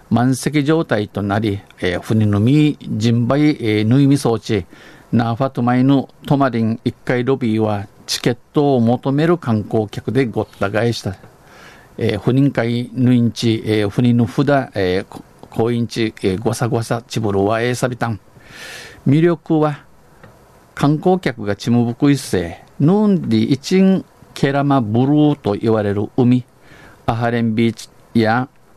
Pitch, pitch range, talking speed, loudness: 120 Hz, 110-140 Hz, 270 characters per minute, -17 LUFS